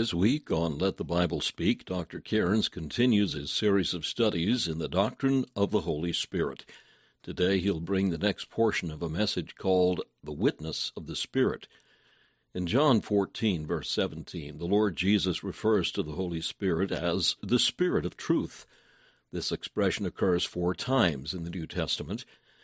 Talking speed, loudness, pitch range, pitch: 165 wpm, -29 LUFS, 85-105 Hz, 95 Hz